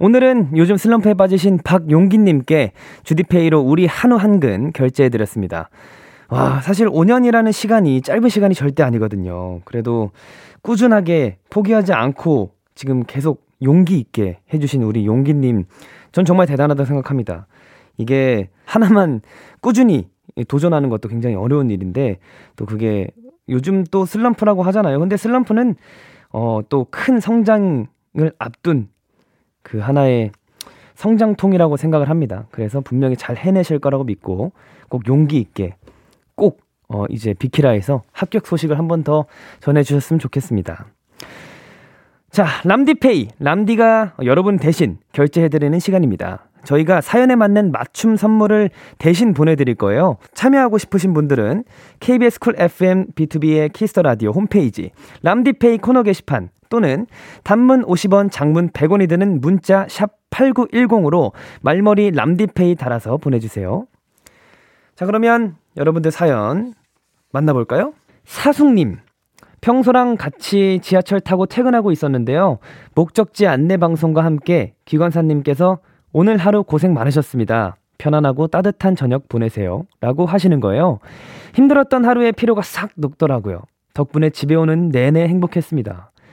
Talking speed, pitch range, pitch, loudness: 310 characters per minute, 130-200 Hz, 160 Hz, -16 LUFS